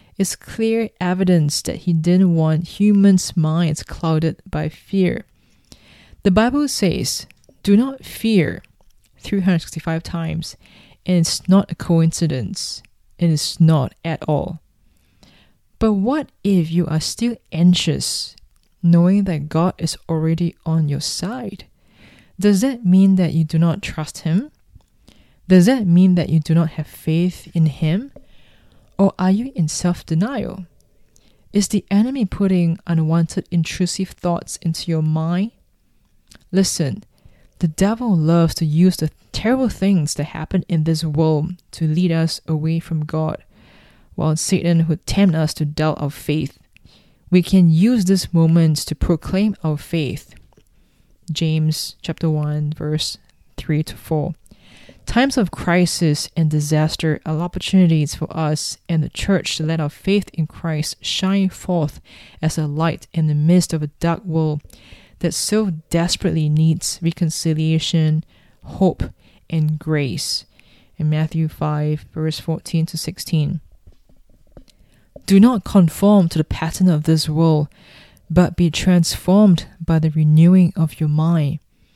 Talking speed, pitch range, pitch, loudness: 140 wpm, 155-185 Hz, 165 Hz, -18 LUFS